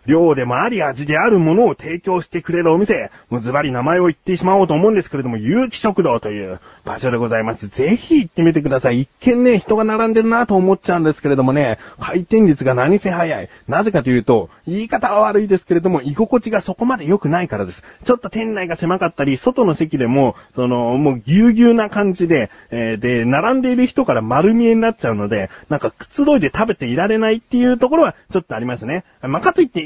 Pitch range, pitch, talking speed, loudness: 135-220 Hz, 175 Hz, 460 characters per minute, -16 LUFS